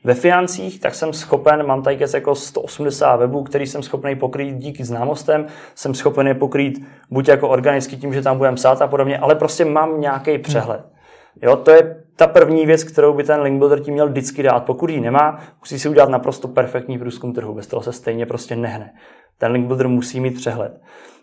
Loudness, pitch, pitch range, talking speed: -17 LUFS, 140 Hz, 130-150 Hz, 205 wpm